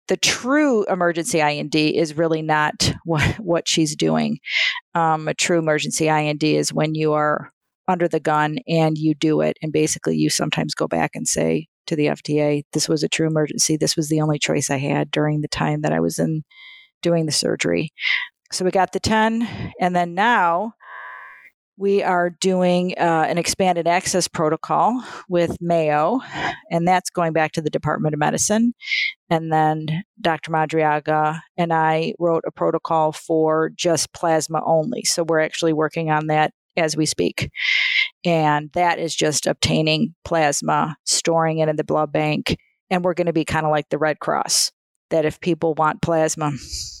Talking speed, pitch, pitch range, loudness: 175 wpm, 160 Hz, 150-175 Hz, -20 LUFS